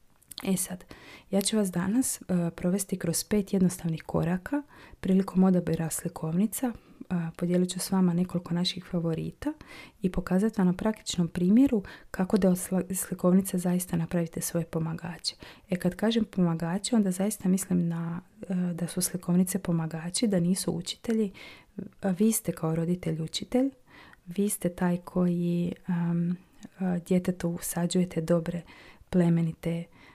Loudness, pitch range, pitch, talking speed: -28 LUFS, 170-195 Hz, 180 Hz, 135 wpm